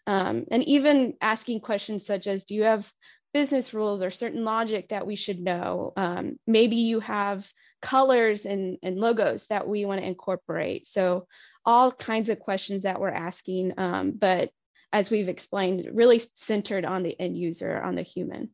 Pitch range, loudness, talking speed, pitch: 190-225 Hz, -26 LUFS, 175 wpm, 205 Hz